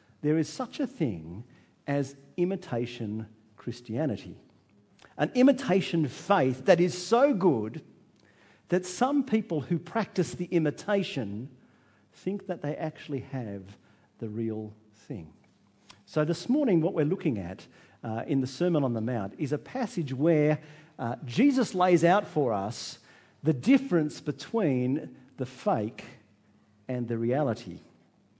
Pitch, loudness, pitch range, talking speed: 150 Hz, -28 LUFS, 120-180 Hz, 125 wpm